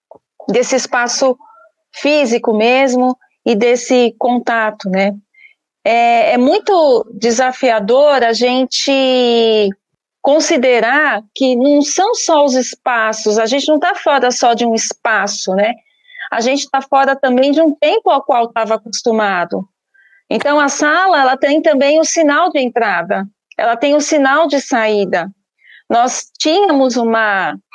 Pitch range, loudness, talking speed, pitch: 225-295 Hz, -13 LUFS, 140 wpm, 255 Hz